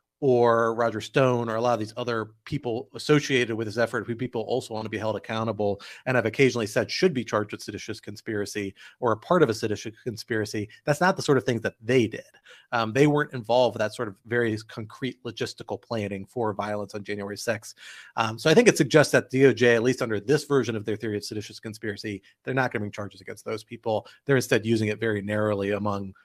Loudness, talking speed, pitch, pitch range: -26 LUFS, 230 wpm, 115 Hz, 105-125 Hz